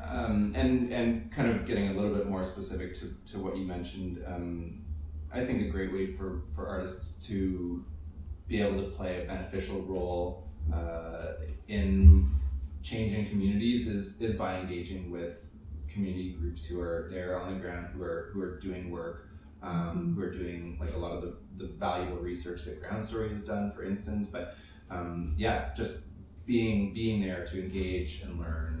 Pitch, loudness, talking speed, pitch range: 90 Hz, -33 LUFS, 180 wpm, 85-100 Hz